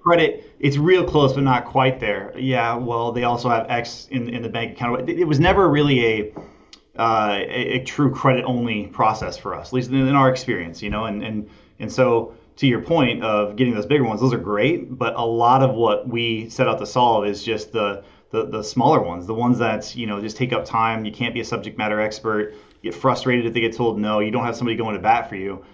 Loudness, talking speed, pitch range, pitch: -20 LUFS, 240 wpm, 110-130 Hz, 115 Hz